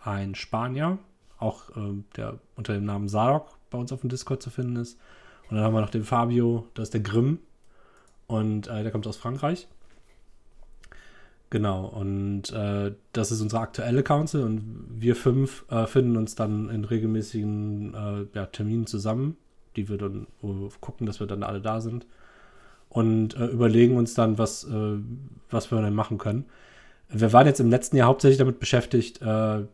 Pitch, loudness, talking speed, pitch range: 110 Hz, -26 LUFS, 180 wpm, 105-120 Hz